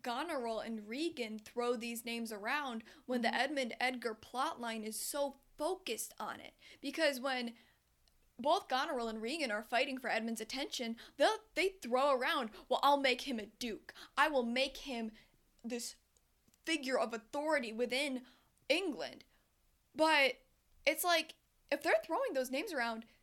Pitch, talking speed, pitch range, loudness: 255 Hz, 145 wpm, 230-285 Hz, -36 LUFS